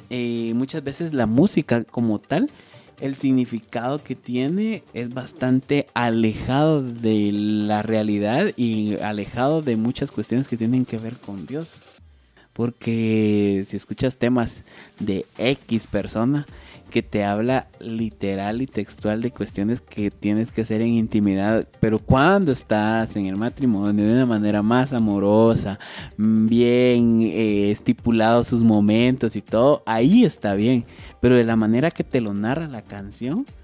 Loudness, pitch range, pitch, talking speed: -21 LUFS, 105-125 Hz, 115 Hz, 145 wpm